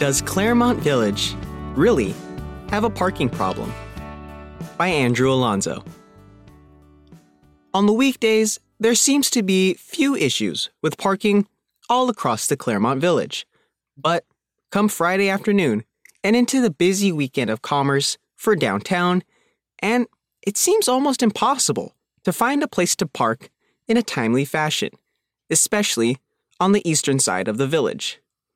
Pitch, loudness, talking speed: 190 Hz, -20 LUFS, 130 wpm